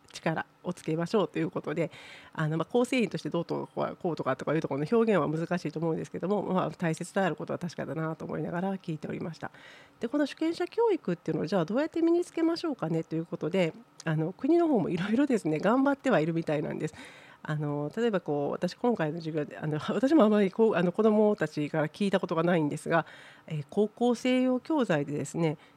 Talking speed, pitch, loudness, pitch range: 460 characters per minute, 180 Hz, -29 LUFS, 160-235 Hz